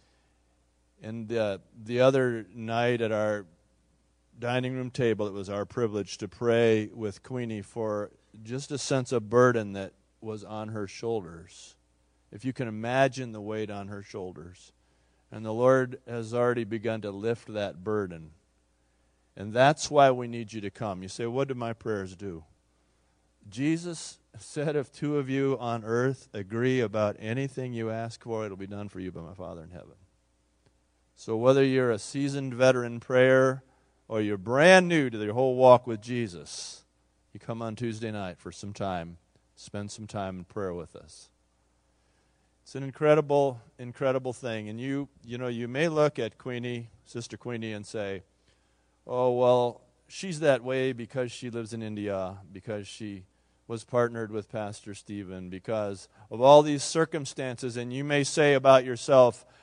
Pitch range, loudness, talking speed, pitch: 95-125 Hz, -28 LUFS, 165 wpm, 110 Hz